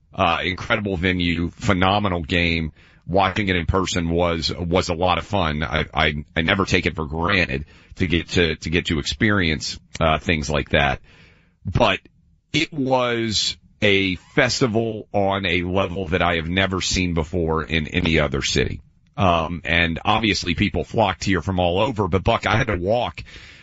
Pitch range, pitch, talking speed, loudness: 85-100 Hz, 90 Hz, 170 wpm, -21 LUFS